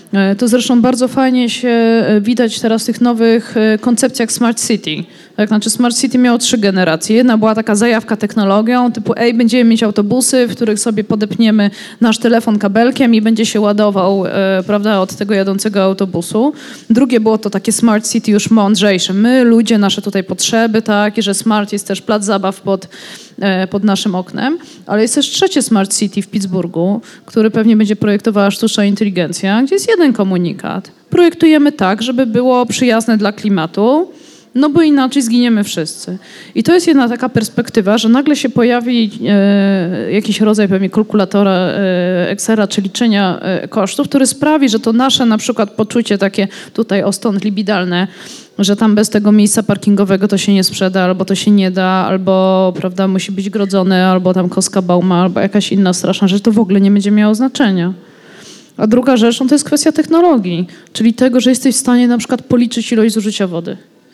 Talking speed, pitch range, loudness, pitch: 180 wpm, 195-240 Hz, -12 LUFS, 215 Hz